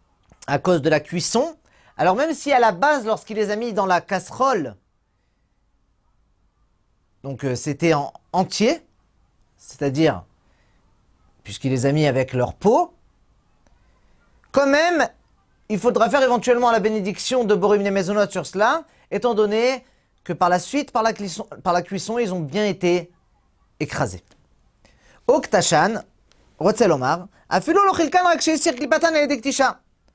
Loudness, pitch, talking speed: -20 LUFS, 205 Hz, 125 wpm